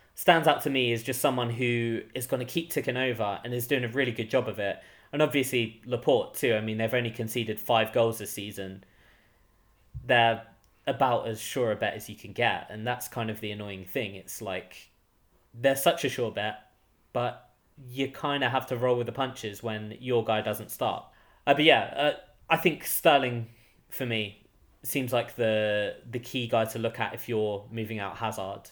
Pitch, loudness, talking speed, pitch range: 115 Hz, -28 LUFS, 205 wpm, 105-125 Hz